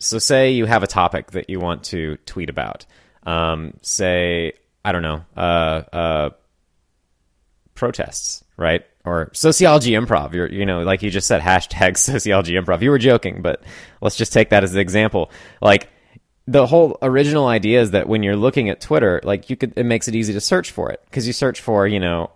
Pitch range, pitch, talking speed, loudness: 85-115 Hz, 100 Hz, 200 wpm, -18 LUFS